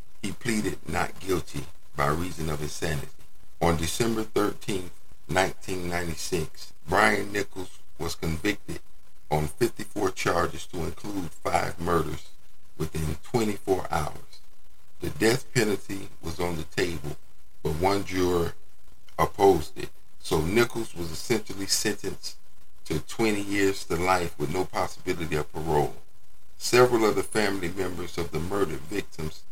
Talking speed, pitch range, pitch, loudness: 125 wpm, 80-100 Hz, 85 Hz, -28 LUFS